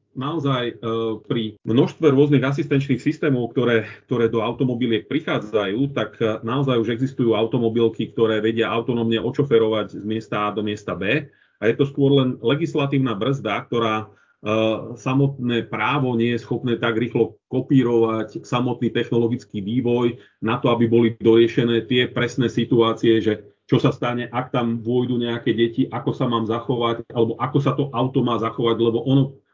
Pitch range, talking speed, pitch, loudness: 115-130 Hz, 155 wpm, 120 Hz, -21 LUFS